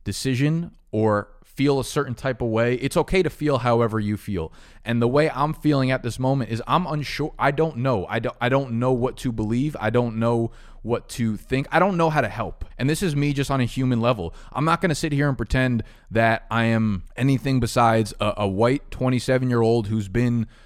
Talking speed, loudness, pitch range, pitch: 230 wpm, -23 LUFS, 115-140 Hz, 125 Hz